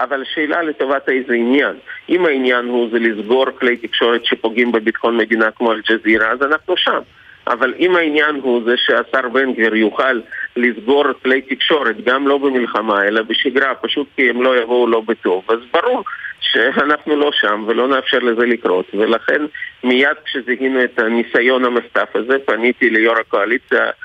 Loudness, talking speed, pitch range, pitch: -15 LUFS, 155 wpm, 115-140 Hz, 125 Hz